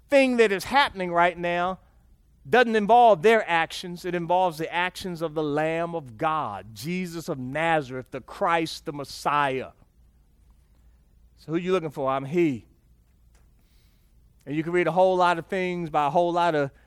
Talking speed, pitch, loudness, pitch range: 170 wpm, 165 Hz, -24 LUFS, 130-180 Hz